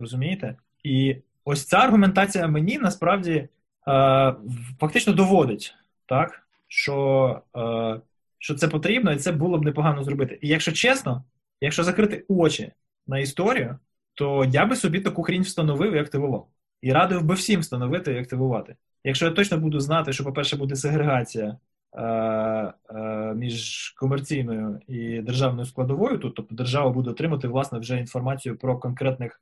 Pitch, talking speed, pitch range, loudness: 135 Hz, 145 wpm, 125-165 Hz, -24 LUFS